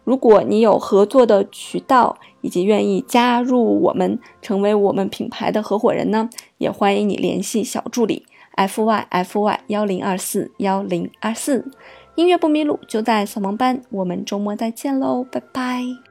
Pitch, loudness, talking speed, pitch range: 215 Hz, -19 LUFS, 255 characters per minute, 195-245 Hz